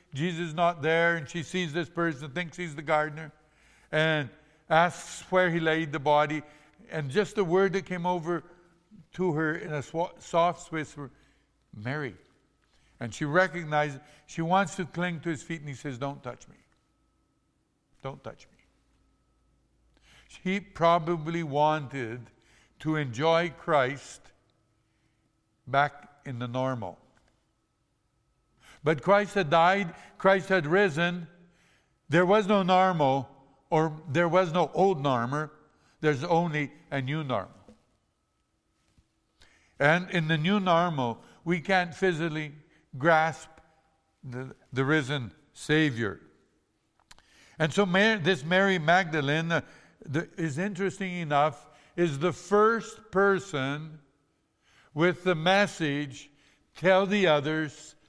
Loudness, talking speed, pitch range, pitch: -27 LUFS, 120 wpm, 145-180 Hz, 160 Hz